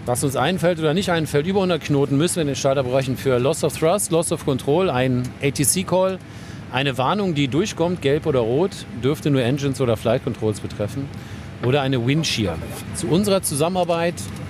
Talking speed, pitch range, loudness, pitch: 180 wpm, 125-170 Hz, -21 LUFS, 140 Hz